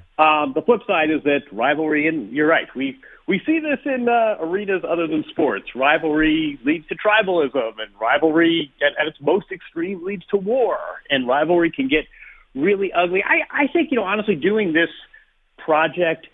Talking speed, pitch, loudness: 180 wpm, 180 Hz, -19 LUFS